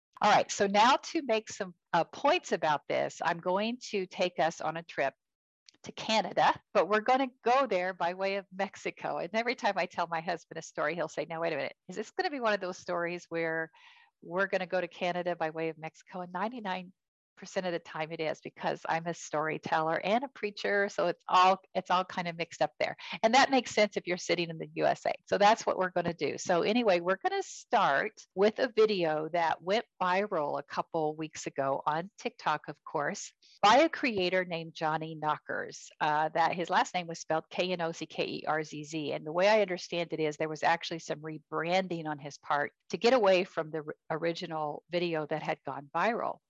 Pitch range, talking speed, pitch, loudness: 160-200 Hz, 220 wpm, 175 Hz, -31 LUFS